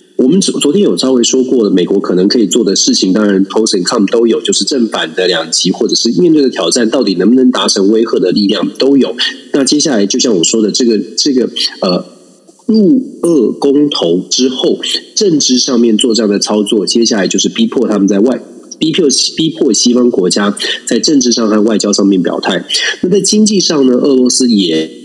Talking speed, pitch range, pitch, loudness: 315 characters per minute, 105-145 Hz, 120 Hz, -10 LUFS